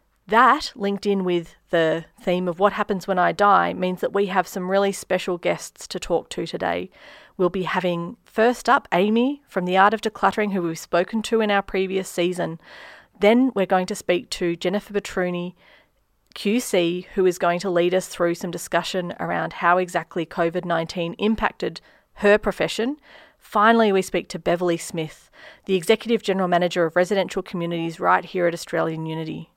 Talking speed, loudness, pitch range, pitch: 175 wpm, -22 LUFS, 175-205 Hz, 185 Hz